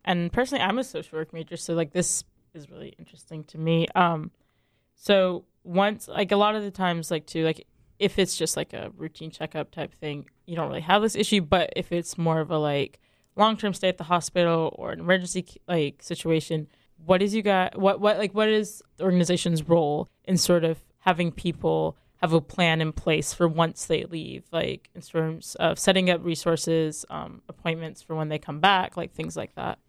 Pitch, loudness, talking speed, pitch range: 170 Hz, -25 LUFS, 210 wpm, 160-185 Hz